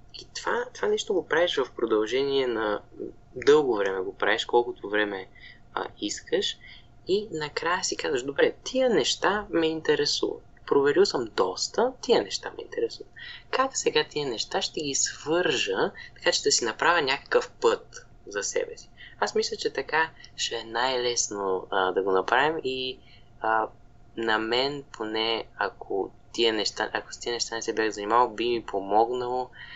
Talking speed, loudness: 160 wpm, -26 LUFS